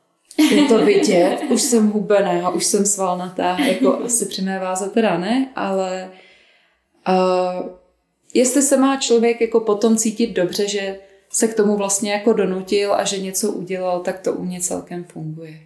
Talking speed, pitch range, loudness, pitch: 170 wpm, 185-230 Hz, -18 LUFS, 200 Hz